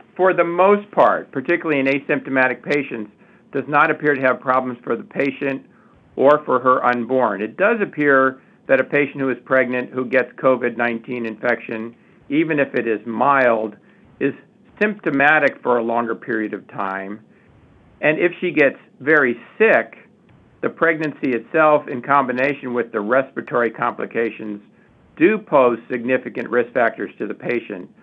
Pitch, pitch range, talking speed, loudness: 130 Hz, 120-150 Hz, 150 wpm, -19 LUFS